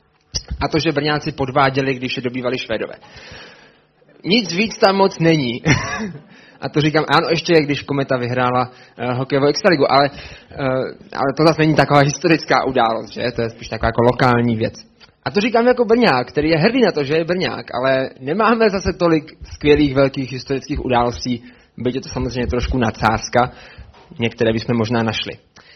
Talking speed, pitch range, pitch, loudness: 170 wpm, 125-160 Hz, 140 Hz, -17 LUFS